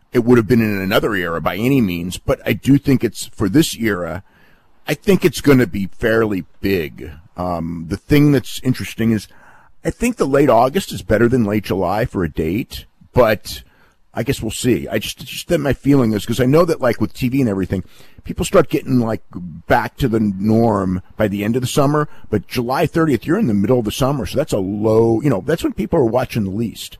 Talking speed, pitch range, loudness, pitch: 230 wpm, 100-135 Hz, -17 LUFS, 115 Hz